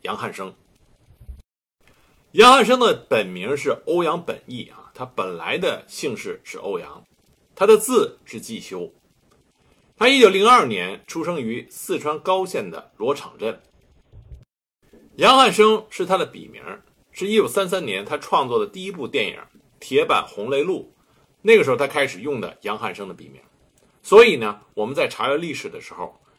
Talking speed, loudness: 235 characters per minute, -19 LUFS